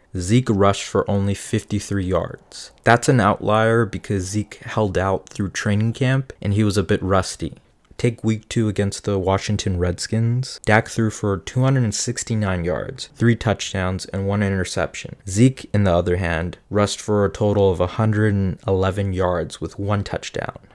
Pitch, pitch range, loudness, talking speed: 100 Hz, 95-110 Hz, -21 LUFS, 155 wpm